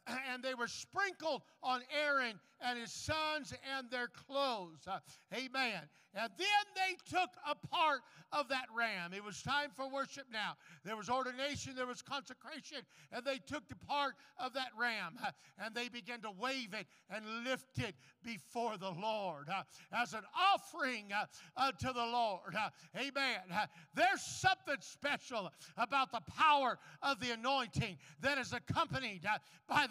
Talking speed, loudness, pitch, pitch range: 165 wpm, -39 LUFS, 250 Hz, 215-275 Hz